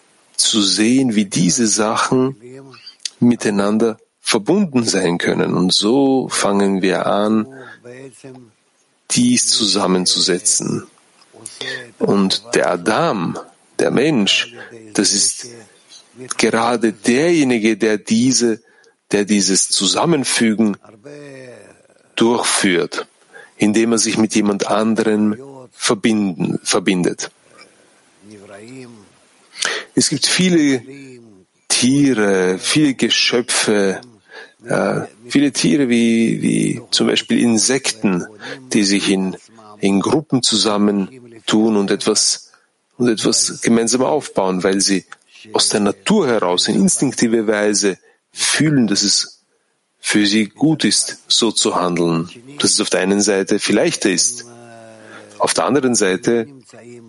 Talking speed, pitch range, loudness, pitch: 100 wpm, 100-125 Hz, -16 LUFS, 110 Hz